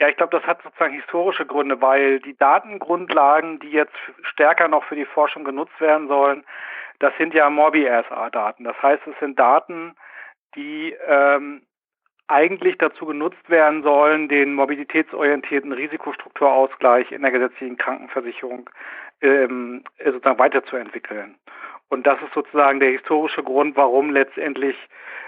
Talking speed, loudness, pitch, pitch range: 135 wpm, -19 LUFS, 145 Hz, 135-155 Hz